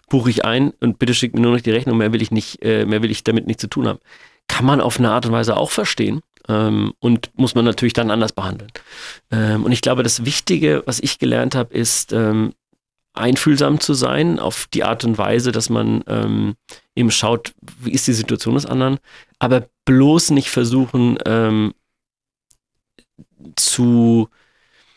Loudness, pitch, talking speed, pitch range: -17 LUFS, 115 Hz, 185 wpm, 110-125 Hz